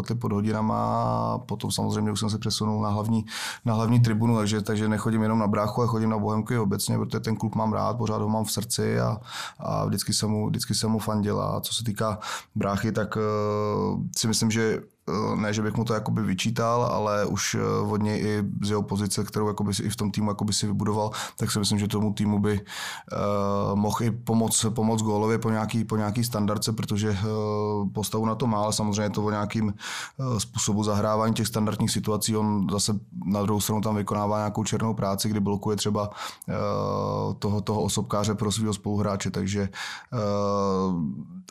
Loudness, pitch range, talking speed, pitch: -26 LUFS, 105-110 Hz, 185 wpm, 105 Hz